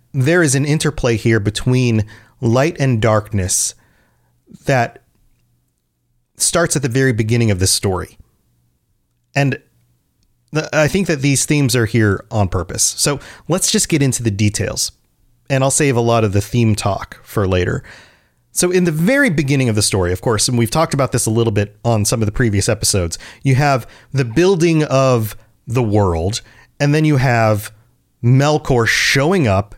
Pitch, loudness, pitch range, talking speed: 120 Hz, -16 LUFS, 105-140 Hz, 170 wpm